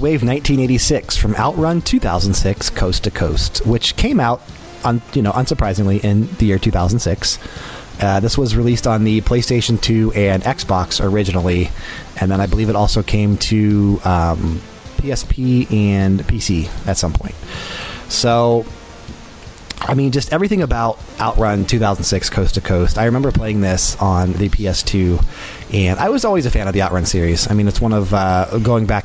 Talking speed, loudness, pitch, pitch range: 165 wpm, -16 LUFS, 100 Hz, 95-115 Hz